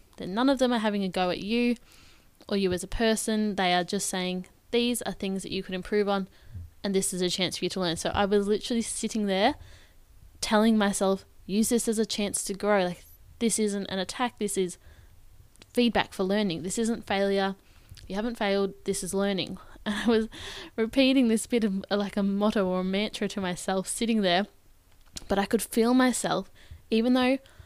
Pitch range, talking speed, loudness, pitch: 185-220 Hz, 205 wpm, -27 LUFS, 200 Hz